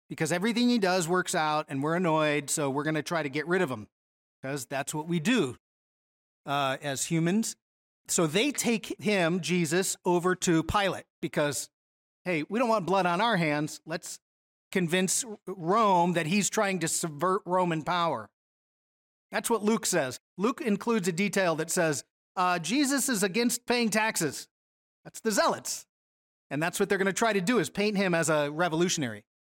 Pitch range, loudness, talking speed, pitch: 150-200 Hz, -28 LUFS, 180 wpm, 175 Hz